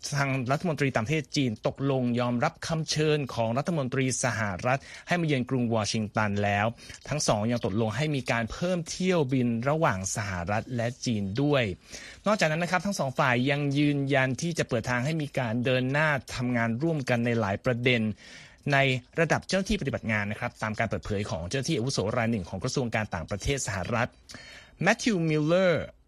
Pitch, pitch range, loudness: 130 Hz, 115-150 Hz, -28 LUFS